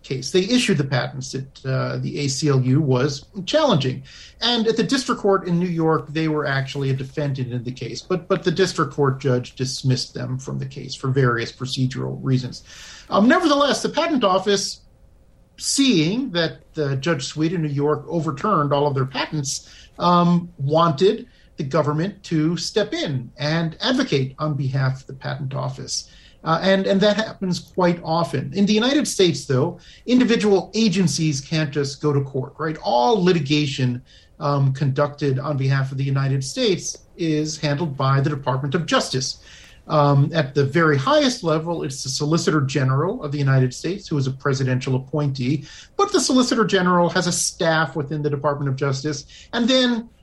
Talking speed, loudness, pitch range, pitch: 175 wpm, -21 LUFS, 135-180 Hz, 150 Hz